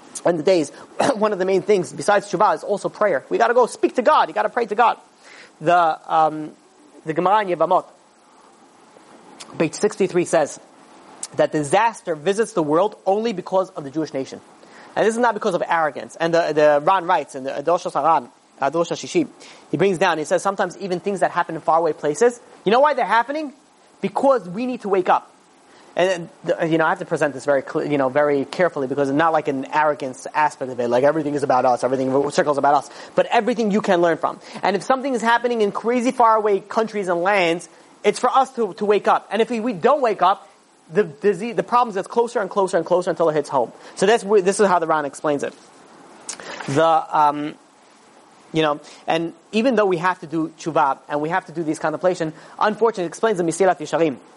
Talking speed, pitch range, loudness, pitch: 210 wpm, 155-210 Hz, -20 LUFS, 180 Hz